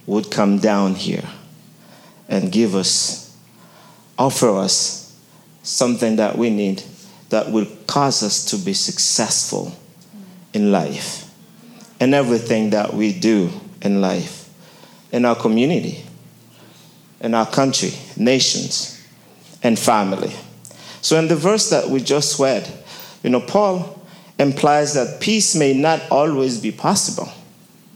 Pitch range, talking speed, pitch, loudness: 115-190 Hz, 120 wpm, 145 Hz, -18 LUFS